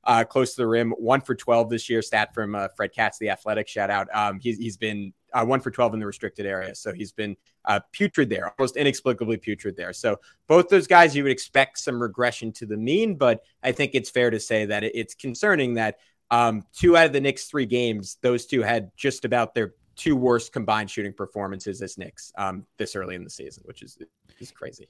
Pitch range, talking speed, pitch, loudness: 105-130 Hz, 230 wpm, 115 Hz, -24 LUFS